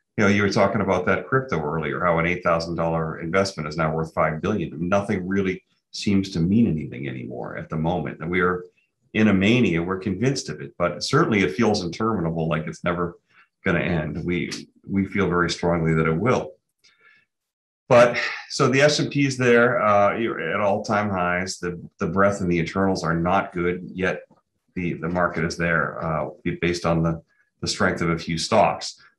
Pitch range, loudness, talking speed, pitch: 85-100 Hz, -22 LUFS, 190 wpm, 90 Hz